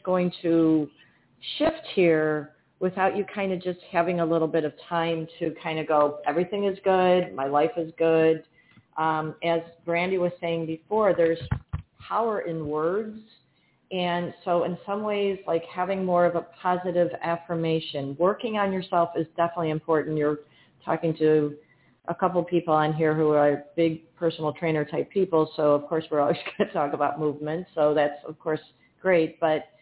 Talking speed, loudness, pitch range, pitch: 170 wpm, -26 LUFS, 155-180 Hz, 165 Hz